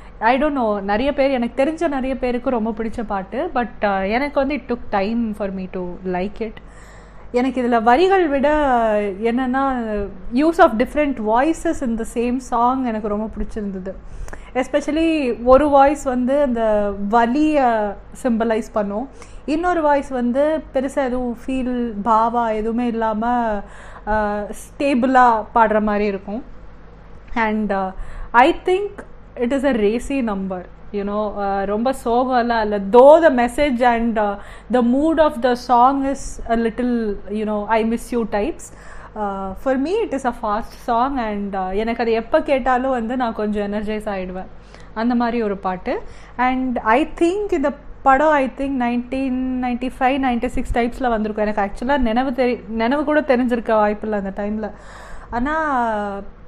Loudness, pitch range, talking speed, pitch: -19 LUFS, 215-265 Hz, 145 wpm, 240 Hz